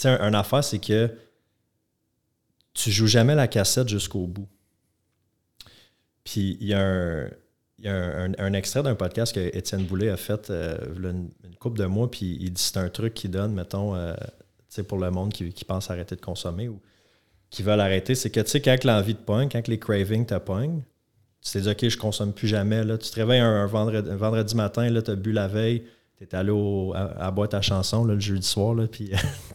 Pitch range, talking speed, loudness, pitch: 95-115 Hz, 230 wpm, -25 LUFS, 105 Hz